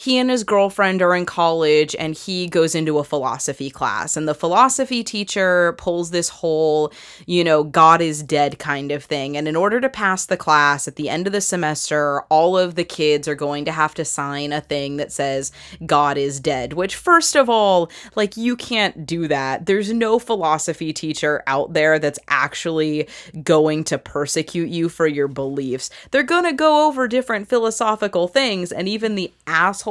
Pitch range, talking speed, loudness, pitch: 150-200 Hz, 190 wpm, -19 LUFS, 165 Hz